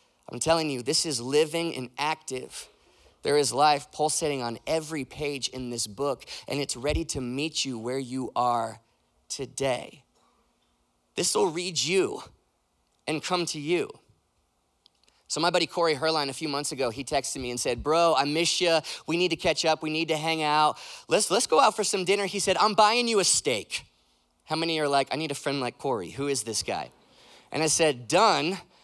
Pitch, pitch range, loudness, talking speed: 150 Hz, 130-165 Hz, -26 LUFS, 200 wpm